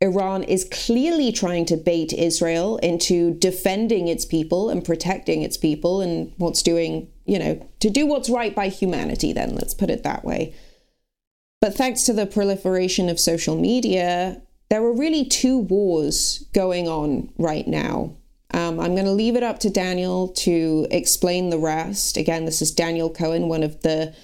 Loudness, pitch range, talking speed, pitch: -21 LUFS, 165-210 Hz, 175 wpm, 180 Hz